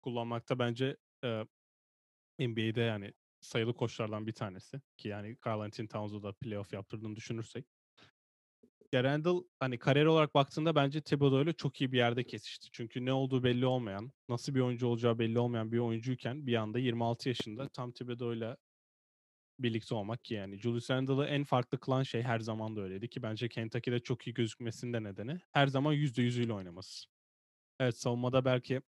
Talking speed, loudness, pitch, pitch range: 160 wpm, -35 LUFS, 120 Hz, 110-130 Hz